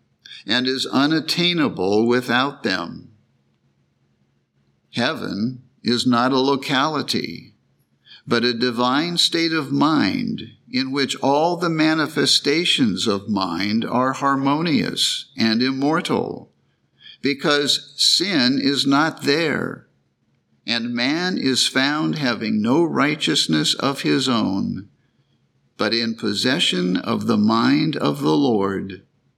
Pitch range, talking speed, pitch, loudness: 115-145 Hz, 105 wpm, 130 Hz, -19 LUFS